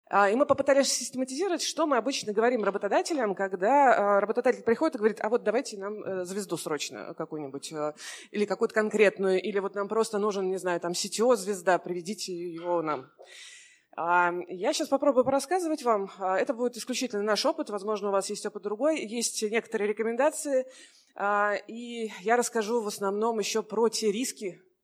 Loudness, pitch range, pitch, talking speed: -28 LUFS, 195-250 Hz, 215 Hz, 155 wpm